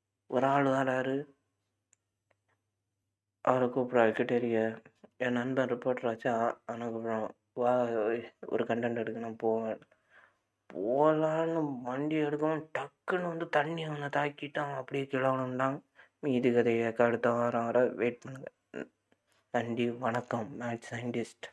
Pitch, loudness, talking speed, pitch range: 120 Hz, -32 LUFS, 105 wpm, 115-135 Hz